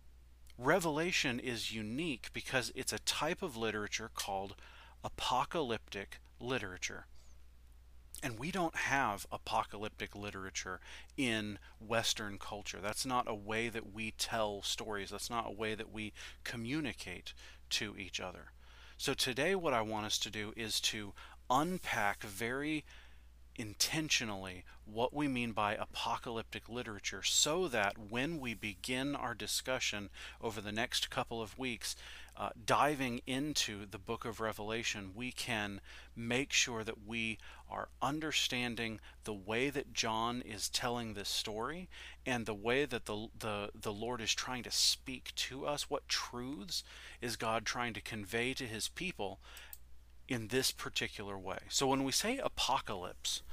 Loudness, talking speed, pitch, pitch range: -37 LUFS, 140 wpm, 110 Hz, 100-120 Hz